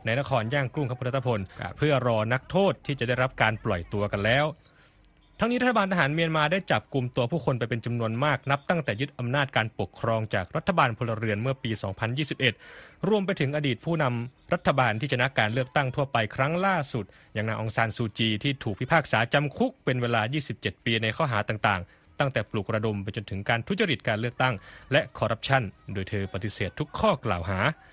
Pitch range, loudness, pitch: 110-150 Hz, -27 LUFS, 125 Hz